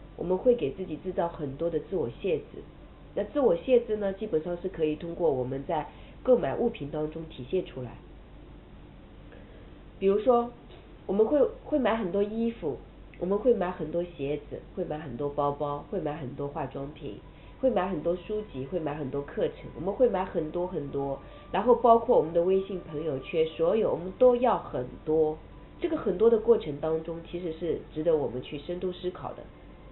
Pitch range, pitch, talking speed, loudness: 150-215 Hz, 175 Hz, 275 characters per minute, -29 LUFS